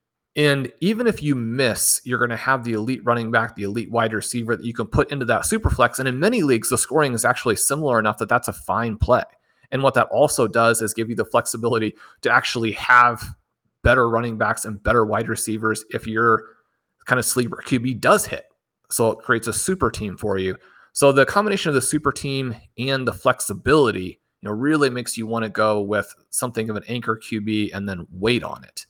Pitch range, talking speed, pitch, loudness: 110-130 Hz, 220 wpm, 115 Hz, -21 LUFS